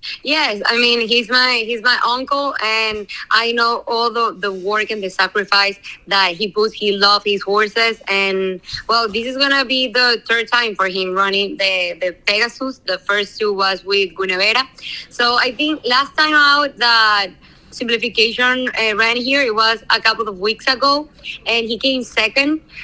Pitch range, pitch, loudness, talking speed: 200-250 Hz, 225 Hz, -15 LUFS, 180 wpm